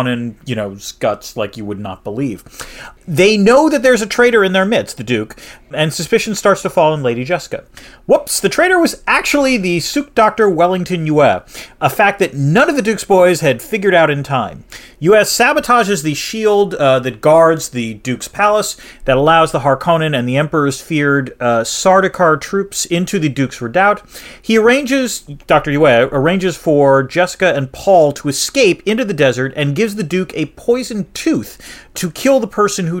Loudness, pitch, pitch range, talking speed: -14 LUFS, 175 Hz, 140-210 Hz, 185 wpm